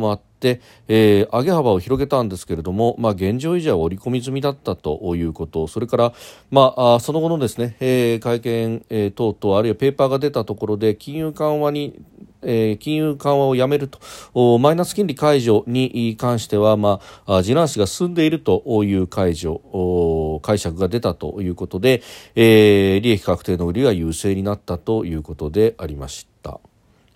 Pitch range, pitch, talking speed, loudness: 95-130 Hz, 110 Hz, 340 characters per minute, -19 LUFS